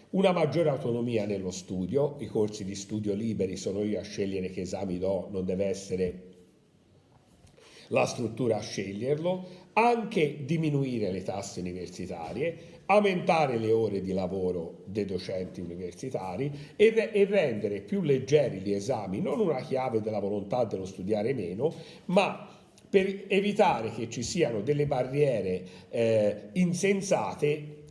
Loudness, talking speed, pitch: -29 LUFS, 140 wpm, 120 Hz